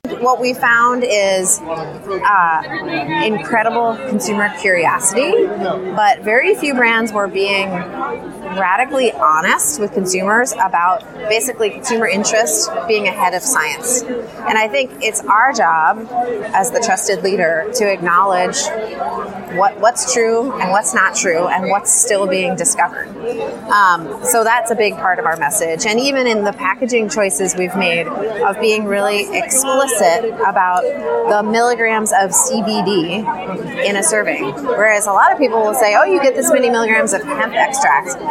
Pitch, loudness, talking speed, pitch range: 220 Hz, -15 LUFS, 150 wpm, 195-240 Hz